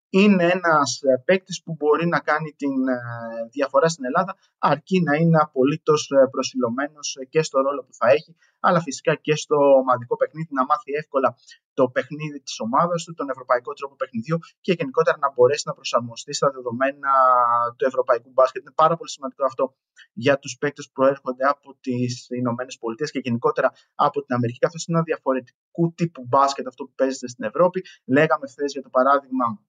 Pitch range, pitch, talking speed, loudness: 130-165 Hz, 140 Hz, 175 wpm, -22 LUFS